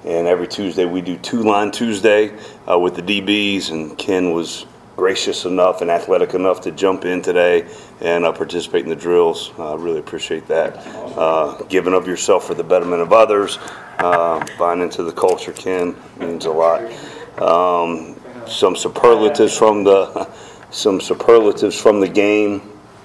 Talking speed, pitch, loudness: 165 wpm, 100 Hz, -16 LUFS